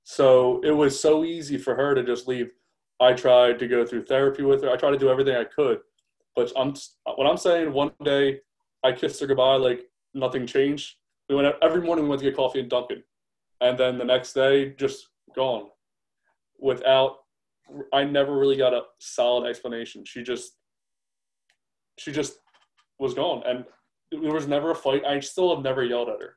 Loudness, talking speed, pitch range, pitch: -23 LUFS, 190 wpm, 125-145 Hz, 135 Hz